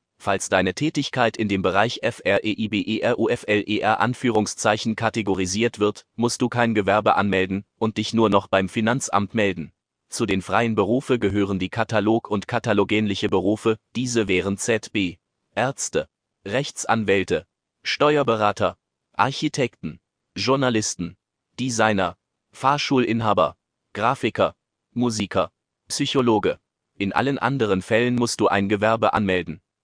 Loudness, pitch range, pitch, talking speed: -22 LUFS, 100-120 Hz, 110 Hz, 110 wpm